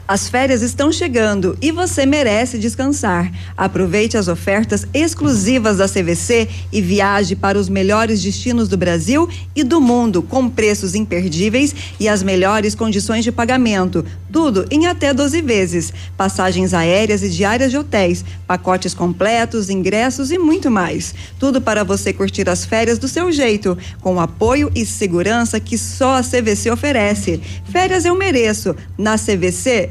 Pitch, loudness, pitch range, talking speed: 210 Hz, -16 LUFS, 185-255 Hz, 150 wpm